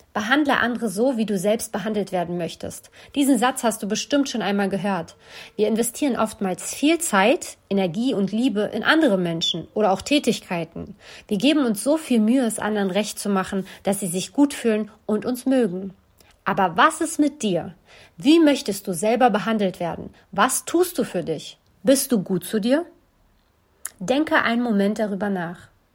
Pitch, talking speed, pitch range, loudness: 215 Hz, 175 wpm, 195-260 Hz, -22 LUFS